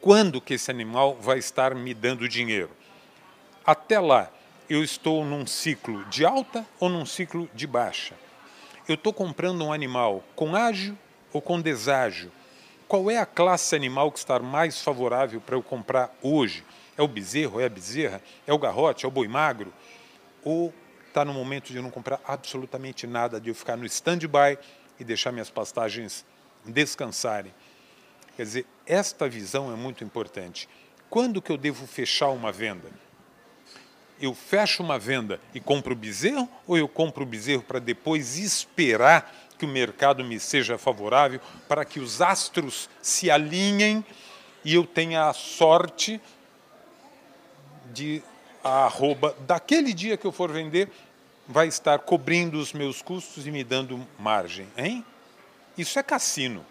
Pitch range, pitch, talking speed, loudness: 130-170 Hz, 145 Hz, 155 wpm, -25 LUFS